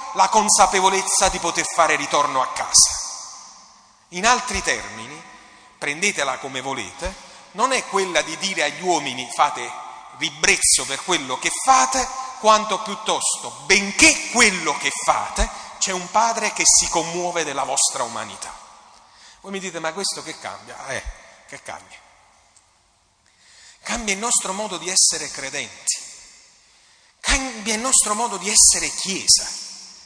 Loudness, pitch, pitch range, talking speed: -18 LUFS, 195 Hz, 175-230 Hz, 130 wpm